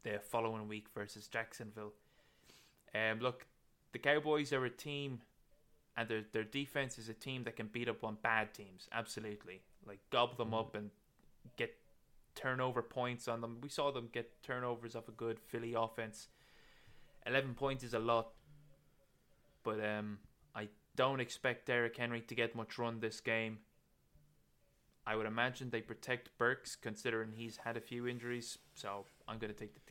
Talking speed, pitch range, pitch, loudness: 165 wpm, 110-125 Hz, 115 Hz, -41 LUFS